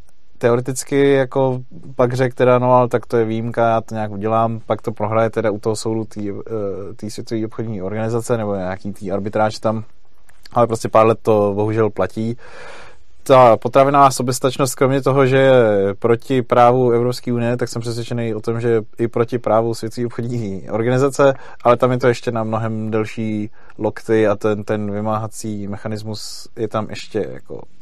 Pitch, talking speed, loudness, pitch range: 115 Hz, 175 wpm, -18 LUFS, 110-125 Hz